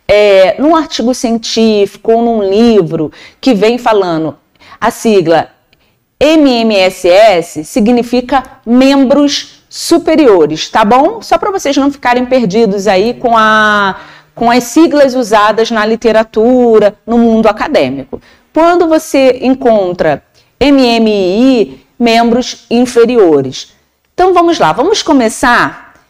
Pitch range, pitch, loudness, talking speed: 215-270 Hz, 235 Hz, -9 LUFS, 110 wpm